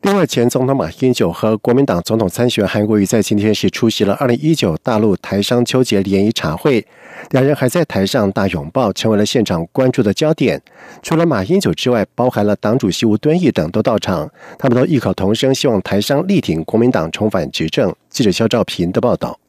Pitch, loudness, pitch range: 120 Hz, -15 LUFS, 105-140 Hz